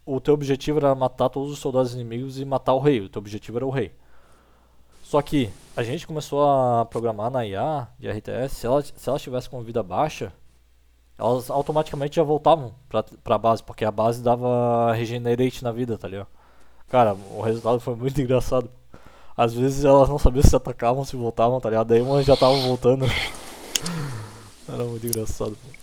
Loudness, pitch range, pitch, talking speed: -23 LUFS, 110-135 Hz, 125 Hz, 185 wpm